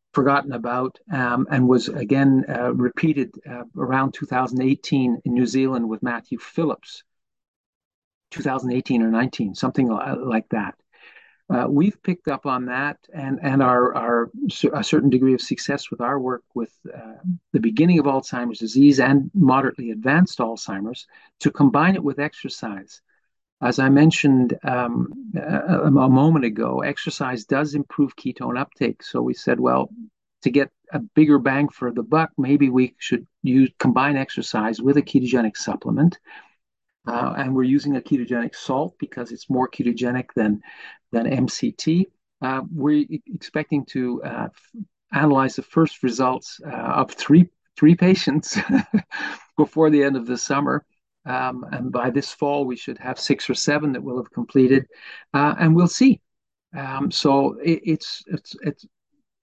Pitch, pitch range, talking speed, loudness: 140 Hz, 125-155 Hz, 150 wpm, -21 LUFS